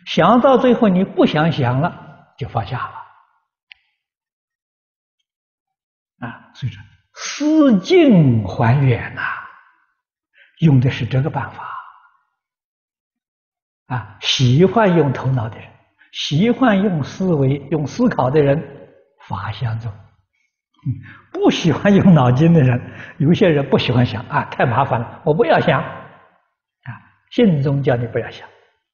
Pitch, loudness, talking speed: 150 Hz, -16 LUFS, 170 characters per minute